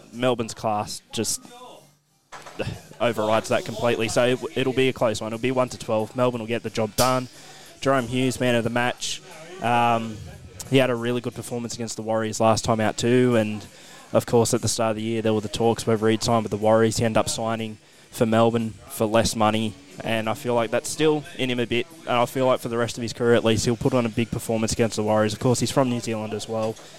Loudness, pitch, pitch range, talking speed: -23 LUFS, 115 Hz, 110-125 Hz, 250 wpm